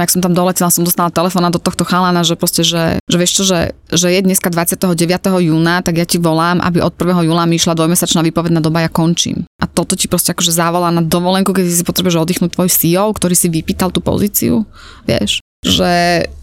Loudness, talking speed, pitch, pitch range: -13 LUFS, 210 wpm, 175 Hz, 170-180 Hz